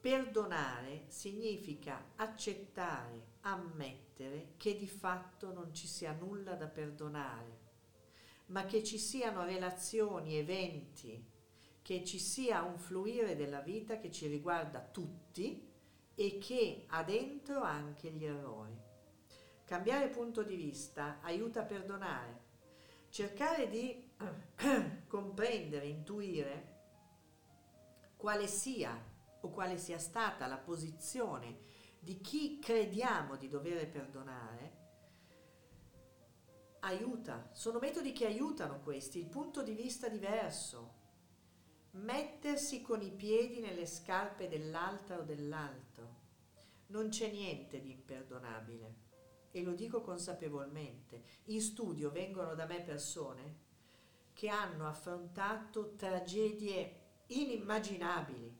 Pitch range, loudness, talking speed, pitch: 135-215 Hz, -42 LUFS, 105 wpm, 175 Hz